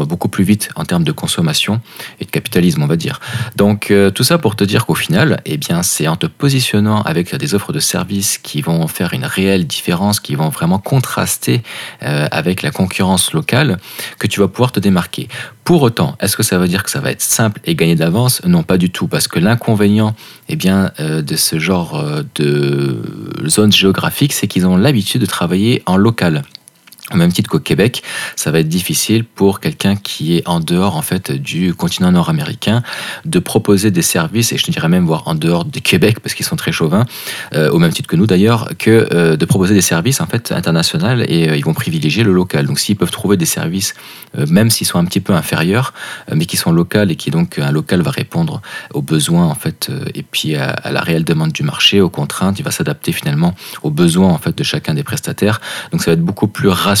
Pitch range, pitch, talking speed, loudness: 90-145 Hz, 105 Hz, 225 wpm, -14 LUFS